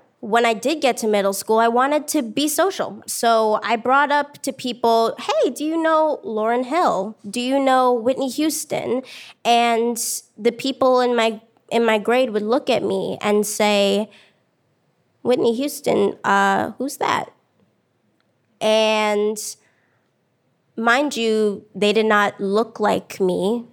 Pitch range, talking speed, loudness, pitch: 210-260 Hz, 145 wpm, -19 LUFS, 230 Hz